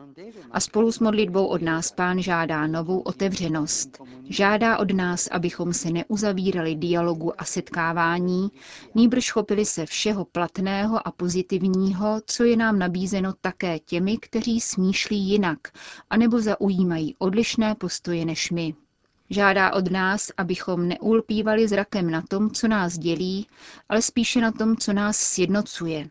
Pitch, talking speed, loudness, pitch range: 190 Hz, 135 wpm, -23 LUFS, 175-215 Hz